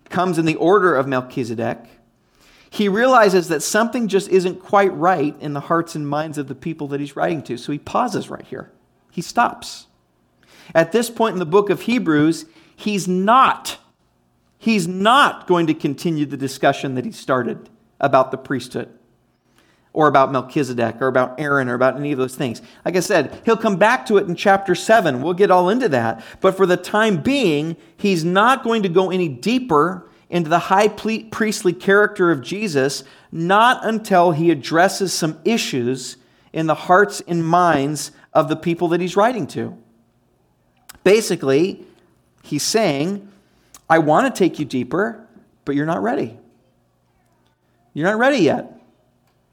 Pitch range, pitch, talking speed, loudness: 135-195 Hz, 165 Hz, 170 wpm, -18 LUFS